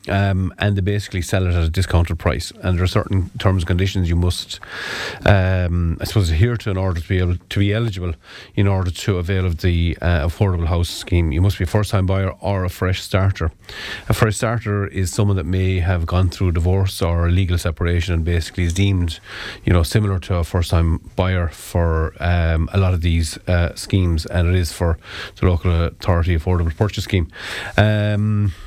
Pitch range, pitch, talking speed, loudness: 85-100 Hz, 90 Hz, 205 wpm, -19 LUFS